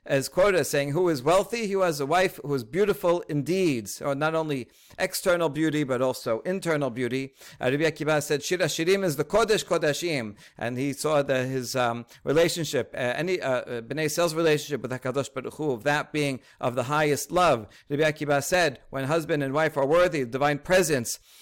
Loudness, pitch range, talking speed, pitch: -26 LUFS, 135-170 Hz, 200 wpm, 150 Hz